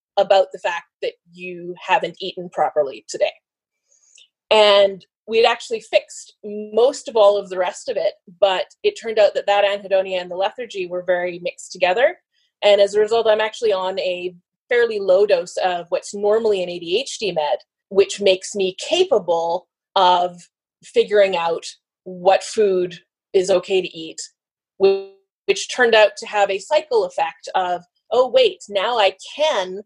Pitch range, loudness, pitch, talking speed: 185-255 Hz, -19 LUFS, 200 Hz, 160 wpm